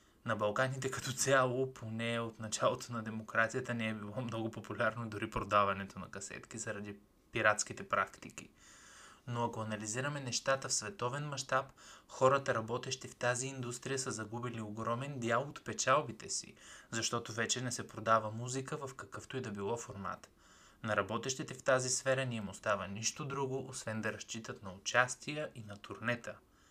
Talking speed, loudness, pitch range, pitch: 155 wpm, -37 LUFS, 110-130 Hz, 120 Hz